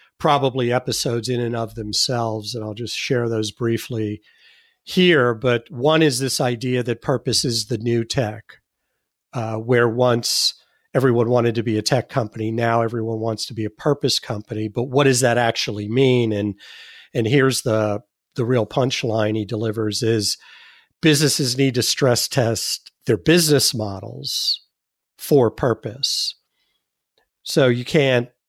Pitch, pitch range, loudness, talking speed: 120 Hz, 110-135 Hz, -20 LUFS, 150 wpm